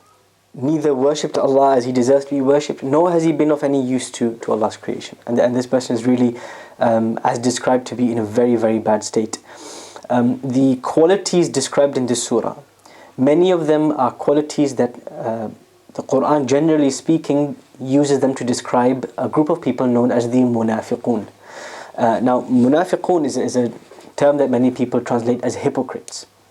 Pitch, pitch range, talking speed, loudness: 130 Hz, 125-145 Hz, 180 wpm, -18 LUFS